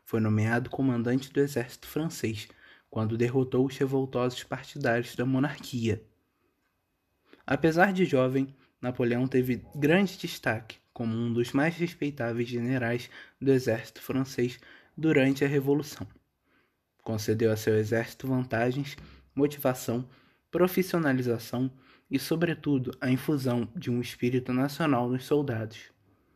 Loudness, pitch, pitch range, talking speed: -29 LUFS, 130 Hz, 120-140 Hz, 110 wpm